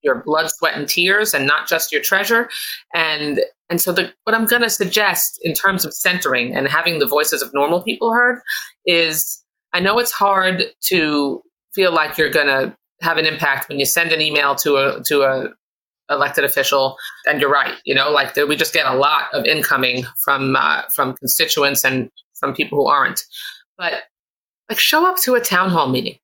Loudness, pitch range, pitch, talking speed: -16 LUFS, 145-215 Hz, 170 Hz, 200 wpm